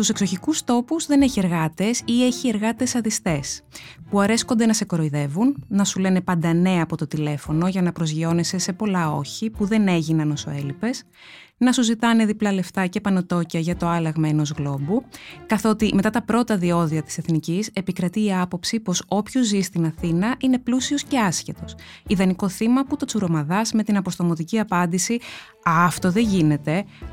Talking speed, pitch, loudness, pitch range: 170 wpm, 190 Hz, -22 LUFS, 165-225 Hz